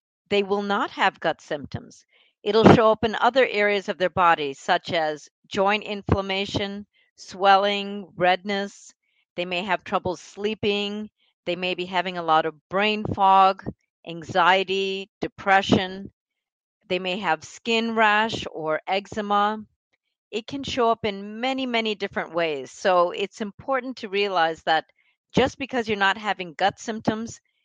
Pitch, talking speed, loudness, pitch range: 200 Hz, 145 wpm, -23 LUFS, 180-215 Hz